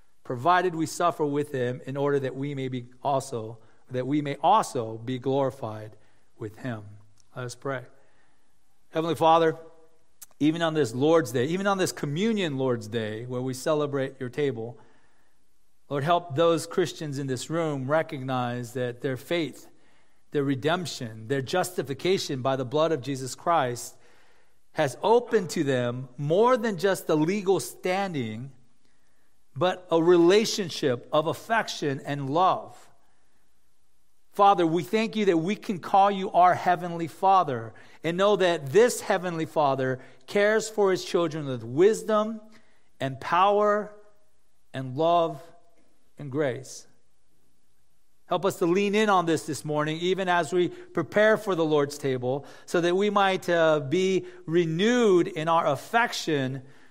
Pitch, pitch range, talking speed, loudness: 155 Hz, 130-180 Hz, 145 wpm, -26 LUFS